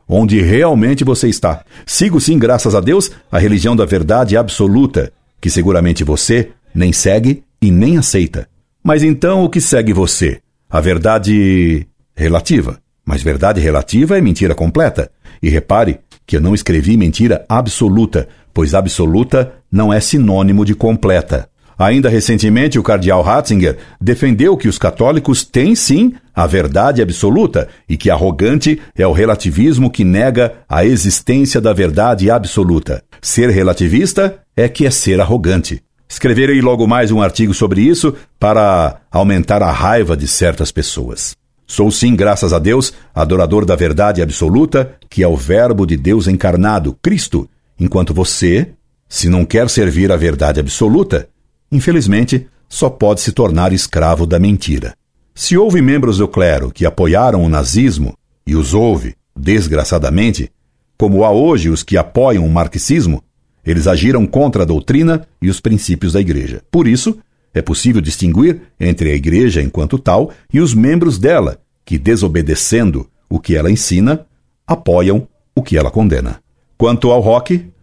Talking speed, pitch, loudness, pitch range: 150 wpm, 100 Hz, -12 LUFS, 85-120 Hz